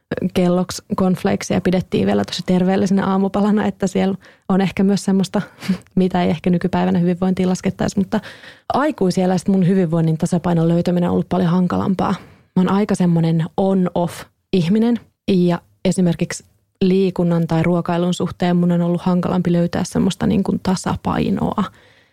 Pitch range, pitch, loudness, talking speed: 175-195 Hz, 185 Hz, -18 LUFS, 130 wpm